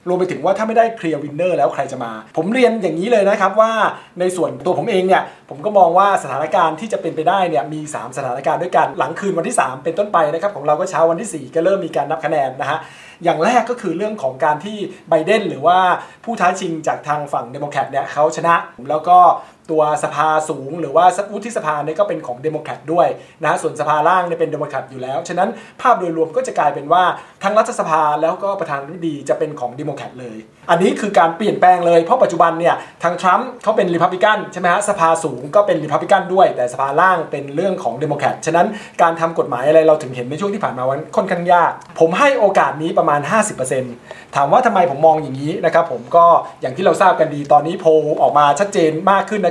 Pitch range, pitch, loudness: 150-195 Hz, 170 Hz, -16 LUFS